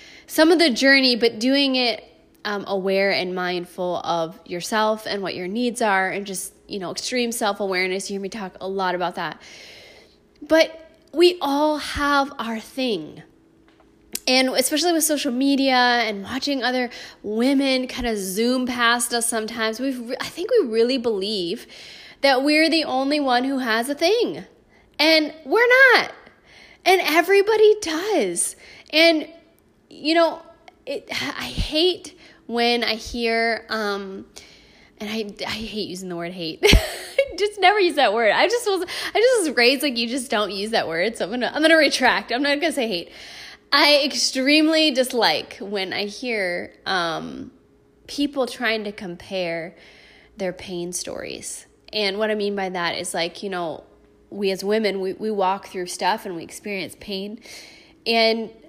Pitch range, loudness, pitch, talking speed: 200-305 Hz, -21 LUFS, 240 Hz, 165 wpm